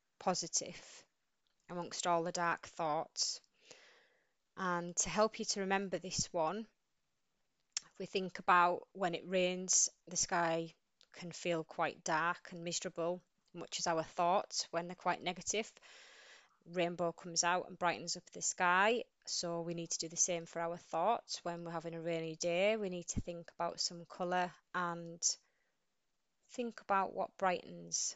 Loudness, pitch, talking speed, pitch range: -37 LUFS, 175 Hz, 155 wpm, 170-185 Hz